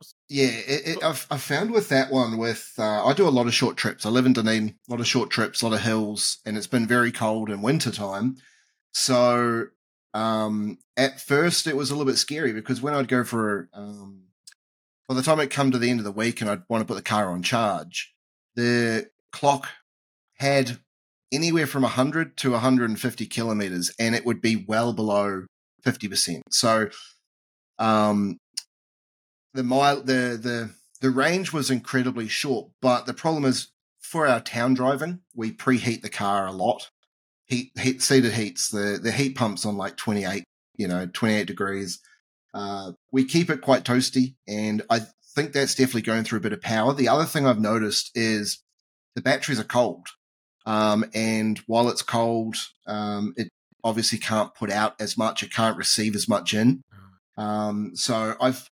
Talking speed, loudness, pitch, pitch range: 190 wpm, -24 LUFS, 115 Hz, 105-130 Hz